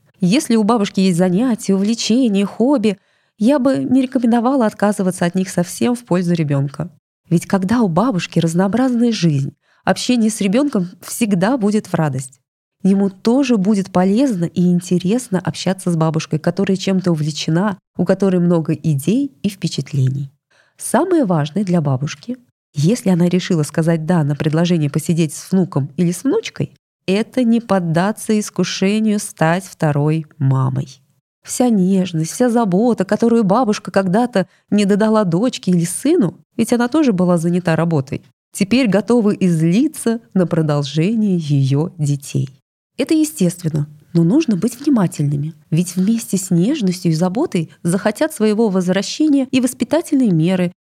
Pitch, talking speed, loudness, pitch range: 190 Hz, 135 wpm, -17 LUFS, 165-225 Hz